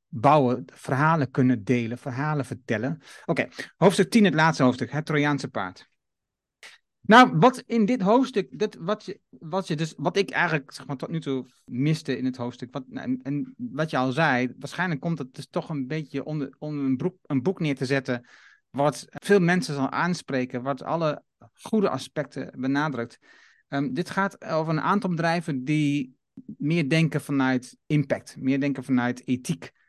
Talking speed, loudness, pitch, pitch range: 175 wpm, -25 LUFS, 145 Hz, 130-170 Hz